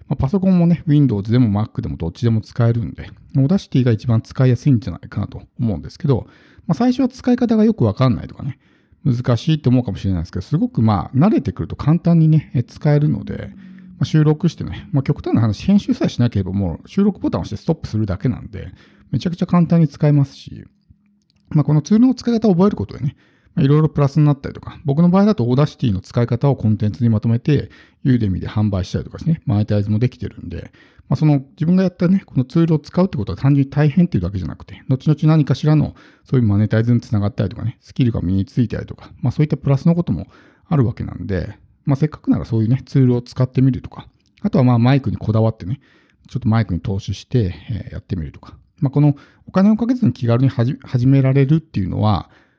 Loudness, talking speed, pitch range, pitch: -18 LUFS, 495 characters per minute, 105-155 Hz, 130 Hz